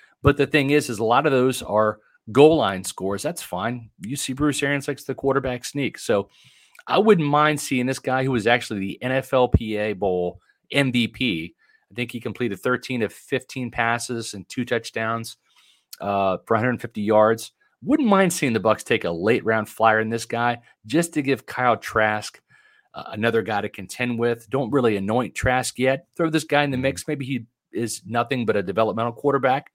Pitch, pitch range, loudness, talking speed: 120 Hz, 110-140 Hz, -22 LUFS, 190 wpm